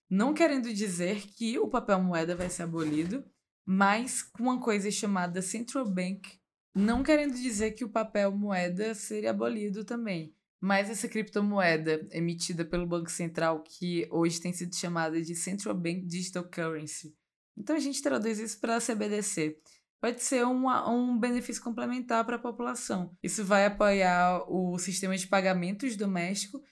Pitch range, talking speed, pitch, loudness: 175-230 Hz, 155 wpm, 200 Hz, -30 LUFS